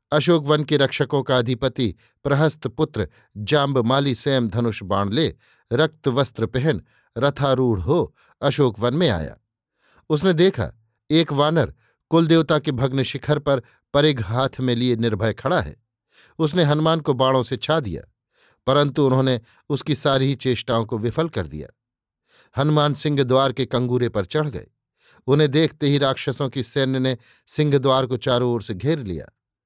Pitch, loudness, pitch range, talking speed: 135 Hz, -21 LUFS, 120-150 Hz, 150 wpm